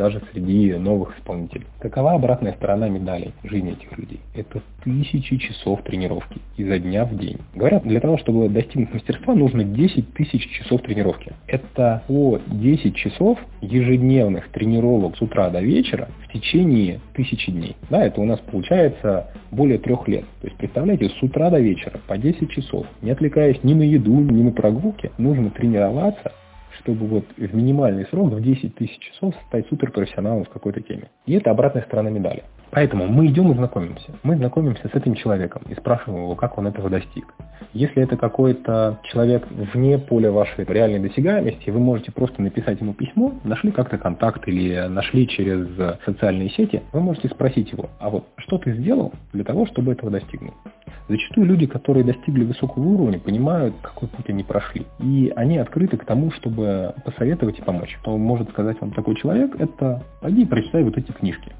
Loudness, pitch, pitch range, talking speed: -20 LUFS, 115 Hz, 105-135 Hz, 170 wpm